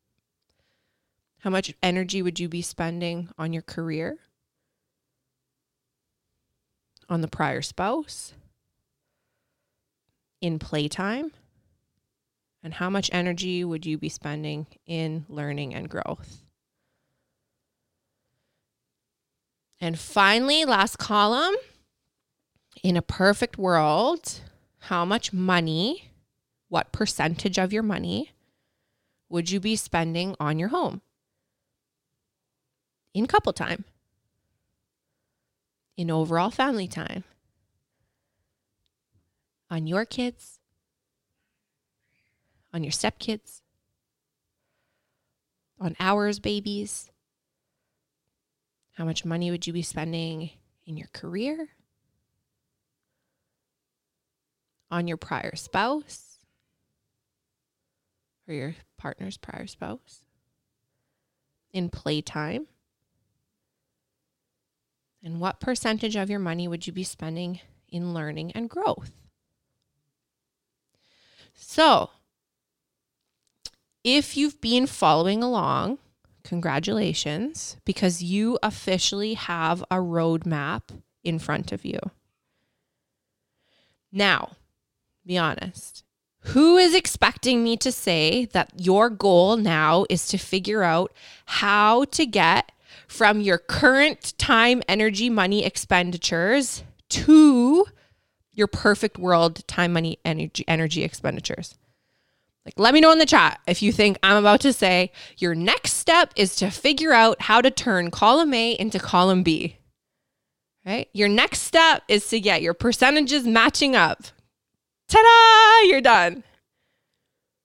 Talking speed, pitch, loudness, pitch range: 100 wpm, 185 Hz, -21 LUFS, 165-225 Hz